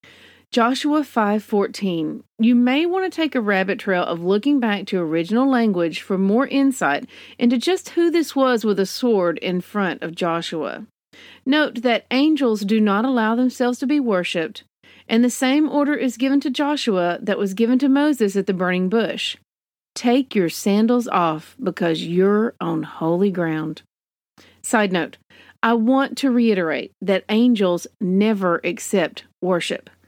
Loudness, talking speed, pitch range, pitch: -20 LUFS, 155 wpm, 185-255 Hz, 220 Hz